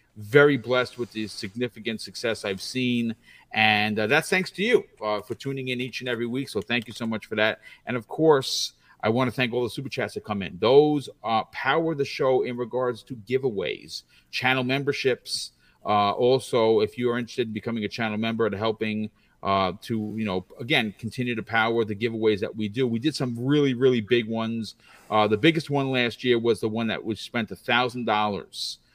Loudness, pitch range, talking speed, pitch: -25 LUFS, 110-130 Hz, 210 wpm, 120 Hz